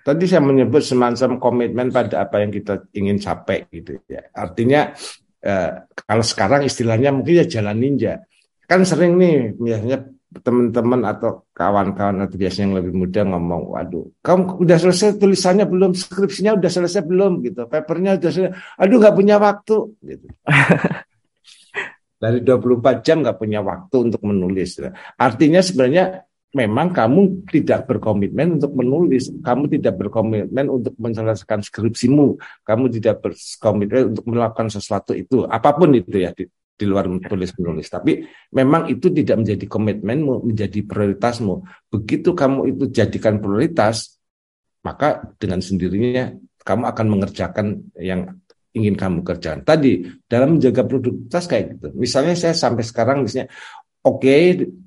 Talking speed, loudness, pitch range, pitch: 140 wpm, -18 LUFS, 105-150 Hz, 120 Hz